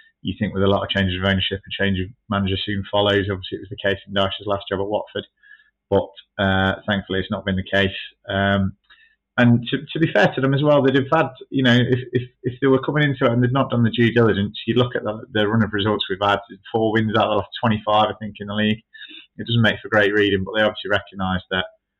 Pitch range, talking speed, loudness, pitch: 100-125 Hz, 260 wpm, -20 LUFS, 105 Hz